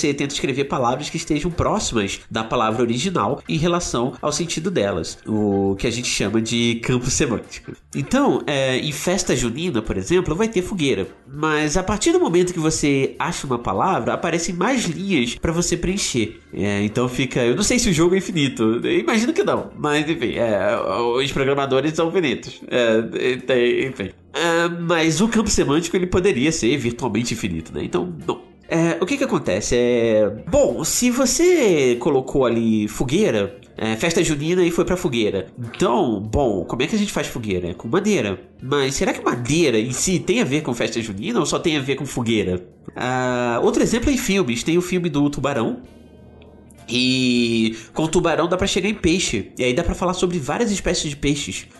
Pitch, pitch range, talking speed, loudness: 145 Hz, 120-180 Hz, 190 wpm, -20 LUFS